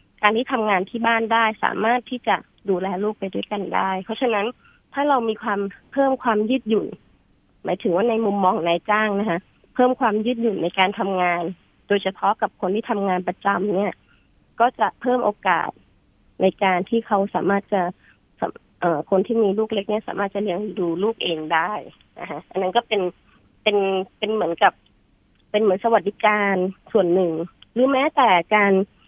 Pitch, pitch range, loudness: 200 Hz, 185-225 Hz, -21 LUFS